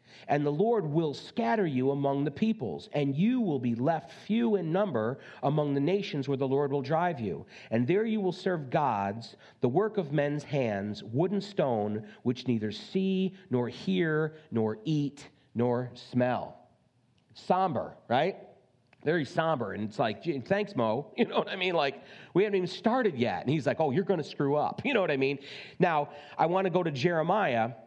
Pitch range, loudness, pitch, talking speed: 130-190 Hz, -30 LUFS, 150 Hz, 190 wpm